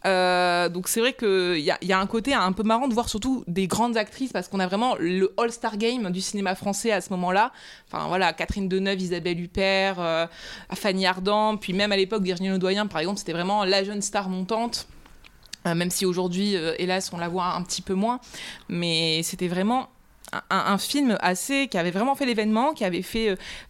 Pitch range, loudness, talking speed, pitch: 180-220 Hz, -24 LUFS, 220 wpm, 195 Hz